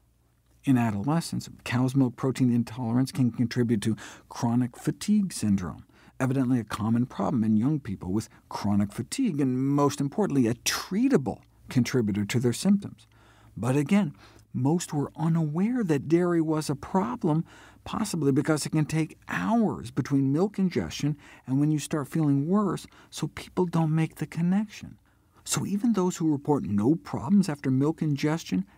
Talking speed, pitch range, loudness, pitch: 150 wpm, 120-165 Hz, -27 LUFS, 140 Hz